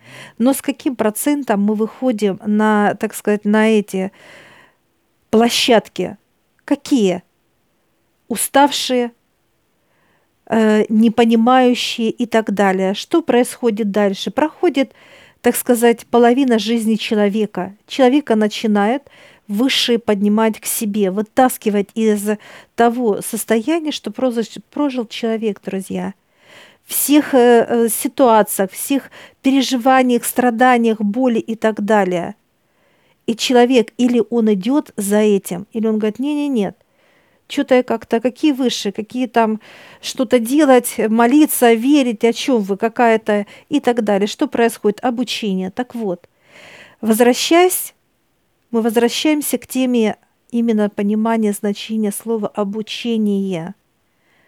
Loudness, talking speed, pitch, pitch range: -16 LUFS, 105 wpm, 230 Hz, 210-250 Hz